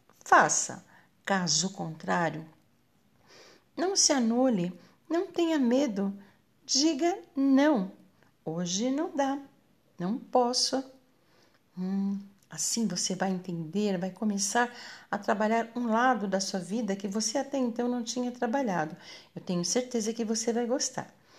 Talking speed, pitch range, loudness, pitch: 125 wpm, 190-260 Hz, -29 LUFS, 230 Hz